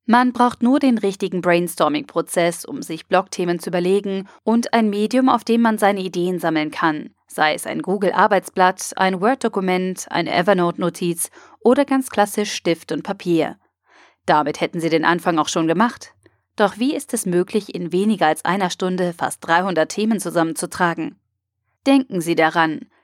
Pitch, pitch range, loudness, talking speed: 185 Hz, 170-215 Hz, -19 LUFS, 155 wpm